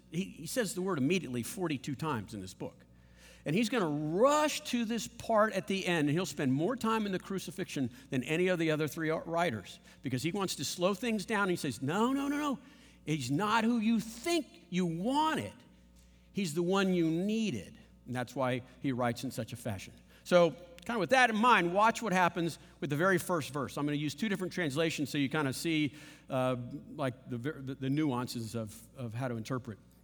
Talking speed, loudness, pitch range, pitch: 220 wpm, -32 LUFS, 130-195 Hz, 160 Hz